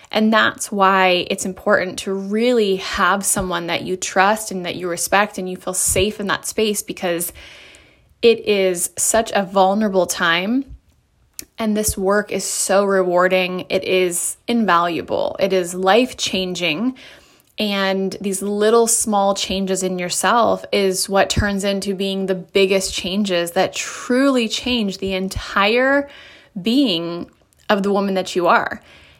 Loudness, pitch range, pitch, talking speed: -18 LUFS, 185-215 Hz, 195 Hz, 145 wpm